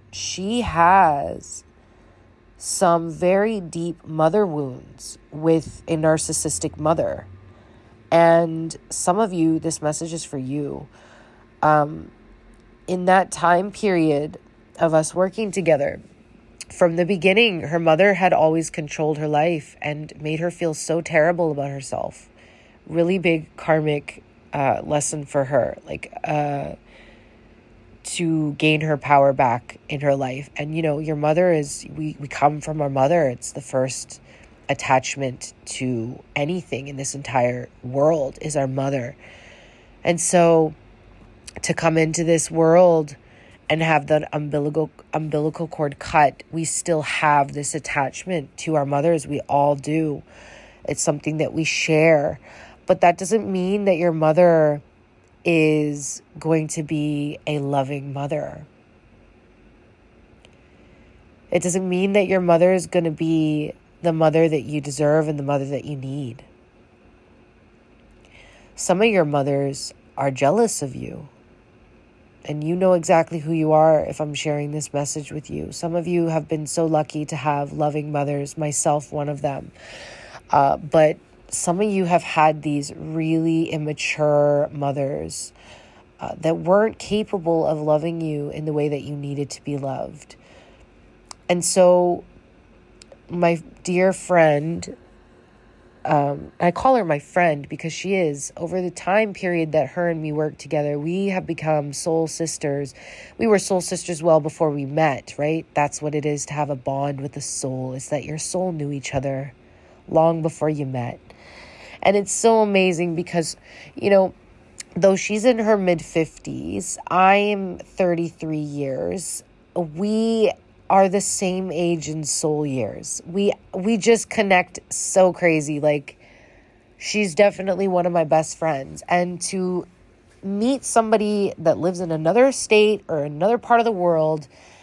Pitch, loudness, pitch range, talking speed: 155 Hz, -21 LUFS, 145-175 Hz, 145 wpm